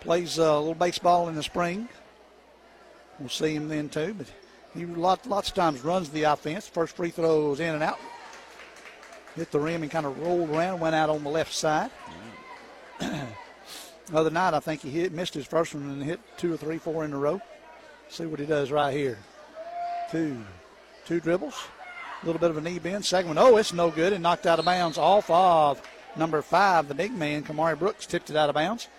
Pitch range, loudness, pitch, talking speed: 155-175 Hz, -26 LUFS, 165 Hz, 210 wpm